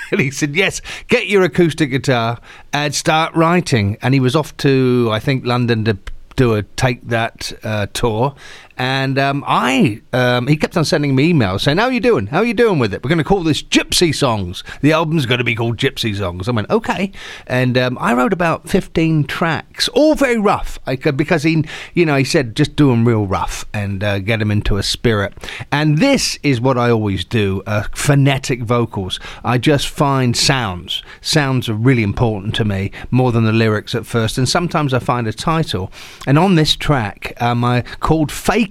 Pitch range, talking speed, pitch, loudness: 115-155 Hz, 210 wpm, 130 Hz, -16 LUFS